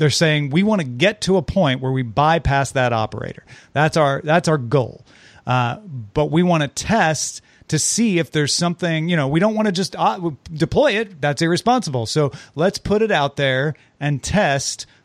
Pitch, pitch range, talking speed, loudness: 150 Hz, 135-175 Hz, 200 wpm, -19 LUFS